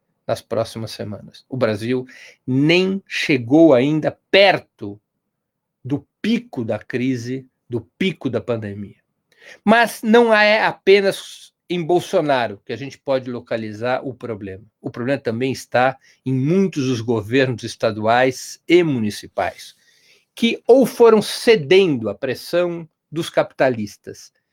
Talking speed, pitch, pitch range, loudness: 120 wpm, 135 Hz, 120-185 Hz, -18 LUFS